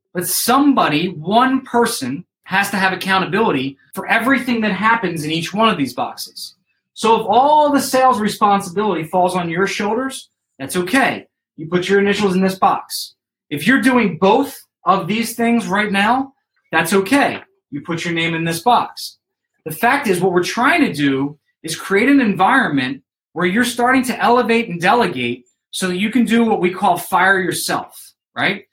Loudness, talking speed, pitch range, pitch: -16 LUFS, 180 wpm, 180-240 Hz, 200 Hz